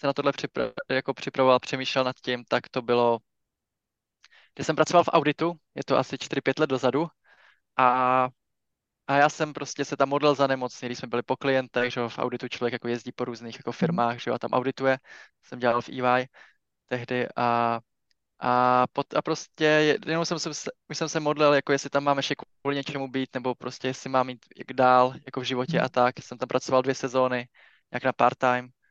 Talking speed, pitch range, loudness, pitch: 200 wpm, 125-140 Hz, -26 LUFS, 130 Hz